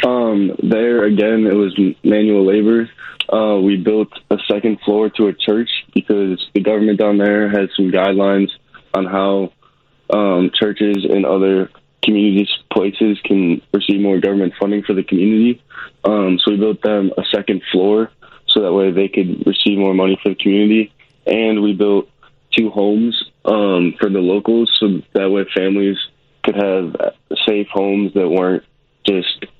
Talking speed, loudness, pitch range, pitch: 160 wpm, -15 LUFS, 95-105 Hz, 100 Hz